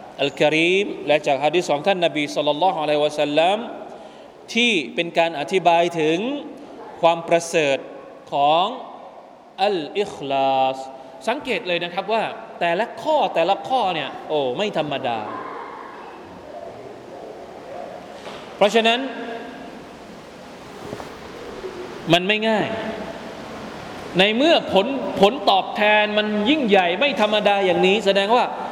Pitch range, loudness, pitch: 170-235 Hz, -20 LUFS, 200 Hz